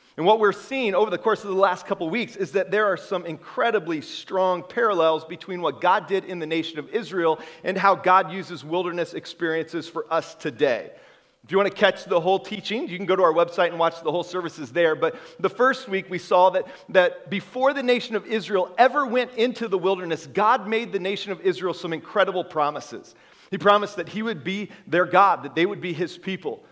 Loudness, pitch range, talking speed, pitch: -23 LUFS, 175-205 Hz, 225 wpm, 185 Hz